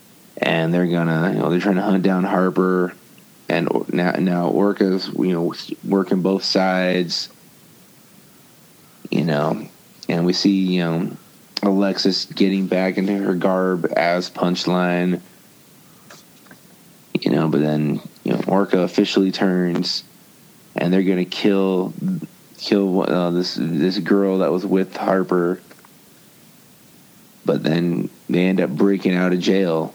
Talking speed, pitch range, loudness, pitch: 130 wpm, 90-95 Hz, -19 LUFS, 90 Hz